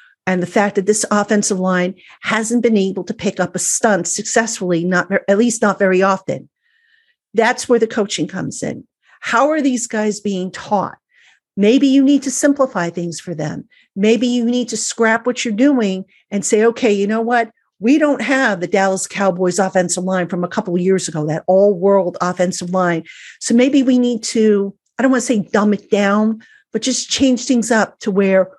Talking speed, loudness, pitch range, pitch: 195 wpm, -16 LUFS, 190-240 Hz, 210 Hz